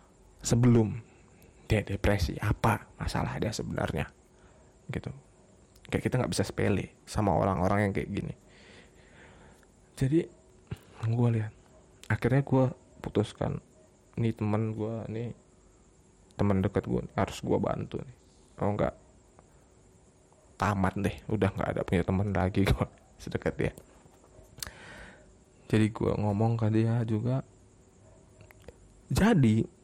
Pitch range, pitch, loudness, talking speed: 95-115 Hz, 105 Hz, -30 LUFS, 115 wpm